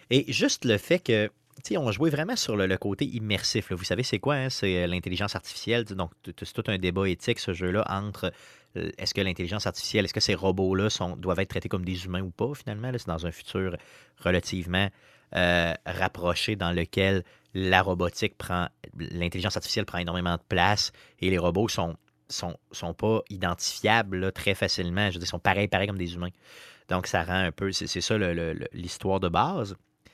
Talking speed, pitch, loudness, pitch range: 205 wpm, 95 Hz, -28 LUFS, 90-105 Hz